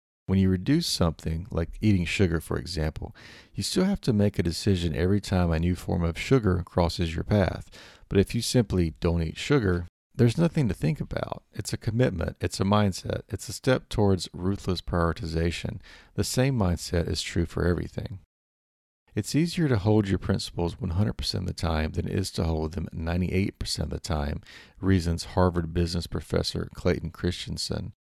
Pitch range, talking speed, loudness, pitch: 85-105 Hz, 175 wpm, -27 LUFS, 90 Hz